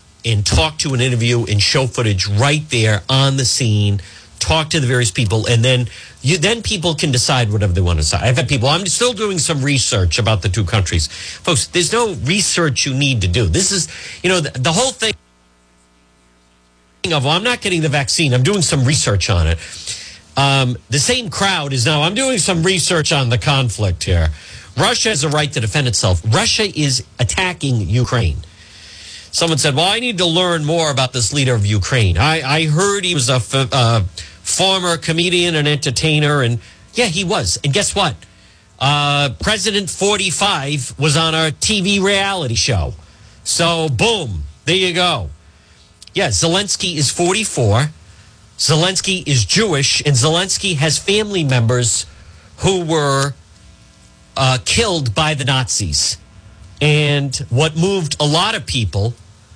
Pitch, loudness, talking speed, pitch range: 135 Hz, -15 LUFS, 170 wpm, 105-165 Hz